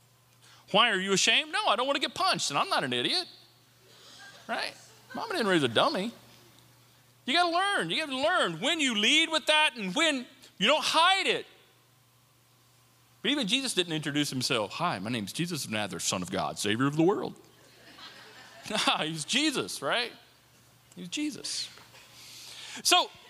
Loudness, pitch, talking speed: -27 LUFS, 225 Hz, 175 wpm